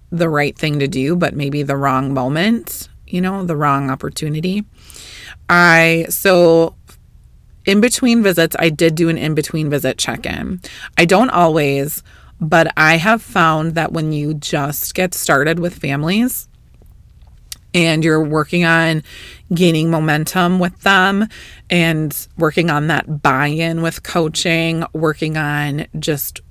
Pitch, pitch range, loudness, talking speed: 165 Hz, 150-175 Hz, -15 LUFS, 145 wpm